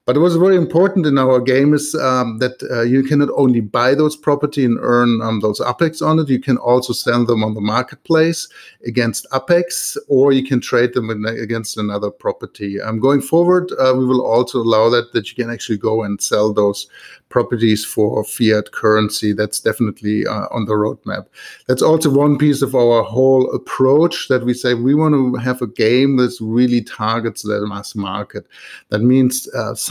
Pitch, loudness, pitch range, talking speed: 125 Hz, -16 LUFS, 110-135 Hz, 195 wpm